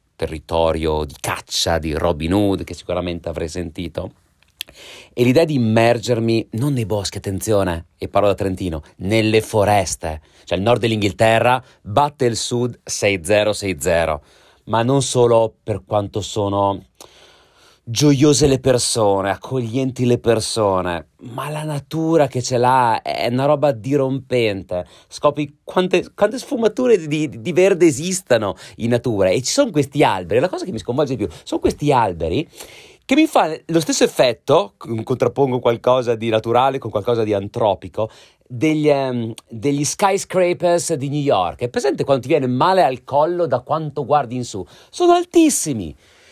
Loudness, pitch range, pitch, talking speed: -18 LUFS, 100-145 Hz, 120 Hz, 150 wpm